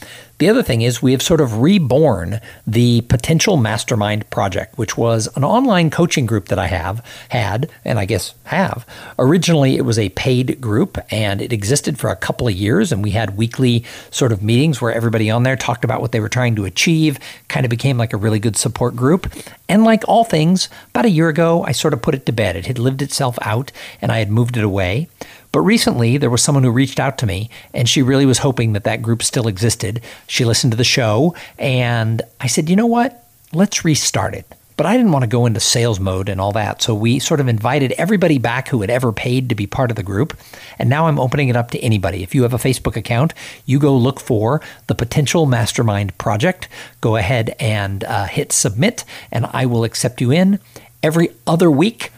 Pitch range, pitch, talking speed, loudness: 115-145 Hz, 125 Hz, 225 wpm, -16 LUFS